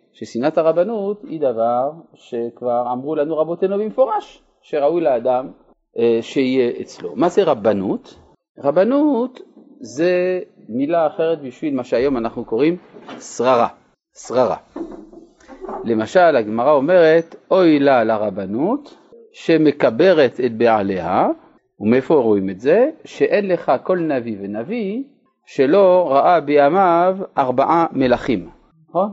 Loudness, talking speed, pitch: -17 LUFS, 105 wpm, 165 Hz